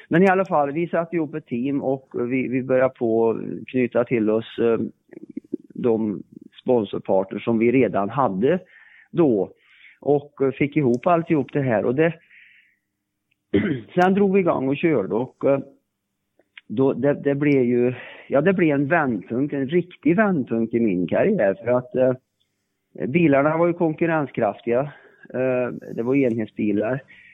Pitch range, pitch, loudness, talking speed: 115-160 Hz, 130 Hz, -21 LUFS, 155 wpm